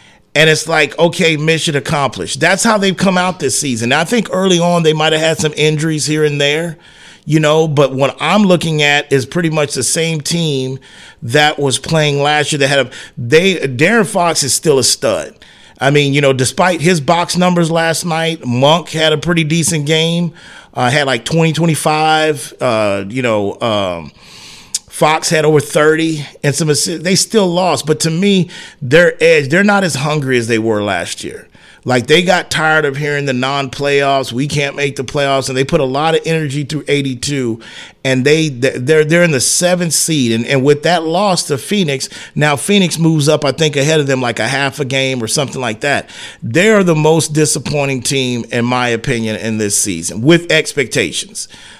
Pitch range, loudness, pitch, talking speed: 135-165 Hz, -13 LUFS, 155 Hz, 200 wpm